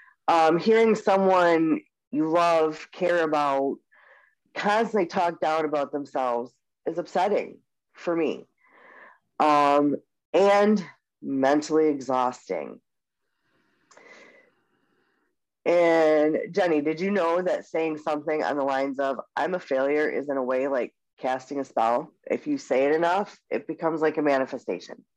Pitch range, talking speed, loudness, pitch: 140-180 Hz, 125 wpm, -24 LUFS, 155 Hz